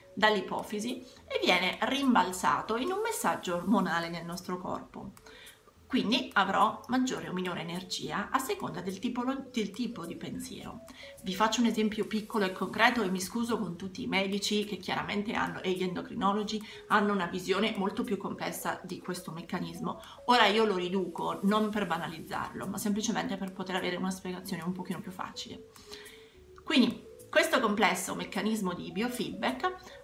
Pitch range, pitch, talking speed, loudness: 190-230 Hz, 205 Hz, 155 wpm, -31 LUFS